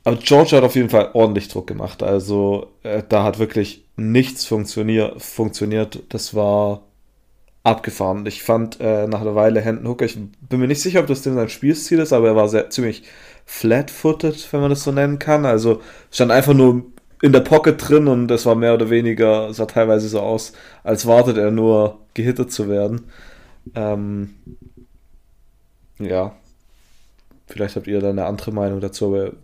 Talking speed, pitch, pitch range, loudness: 175 wpm, 110 Hz, 105-125 Hz, -17 LUFS